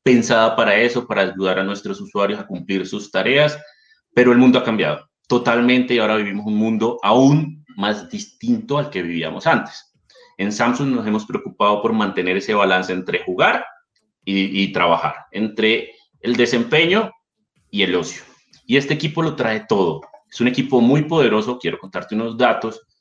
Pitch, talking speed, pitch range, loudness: 120 Hz, 170 wpm, 100-150 Hz, -18 LUFS